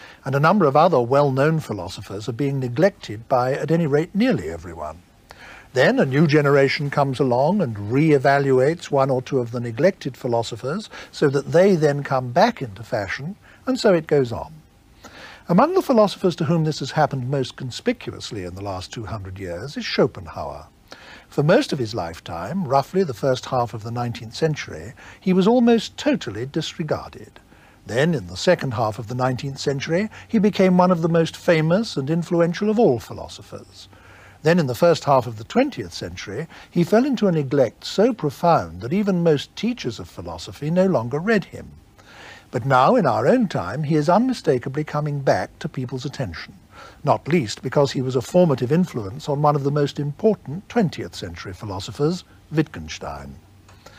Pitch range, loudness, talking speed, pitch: 120-175 Hz, -21 LUFS, 180 wpm, 145 Hz